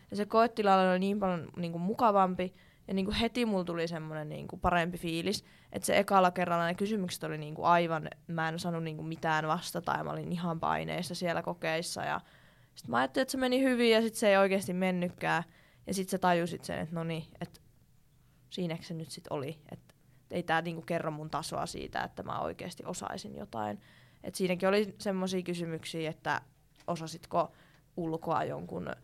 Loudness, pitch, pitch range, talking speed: -32 LUFS, 170 Hz, 160-190 Hz, 175 wpm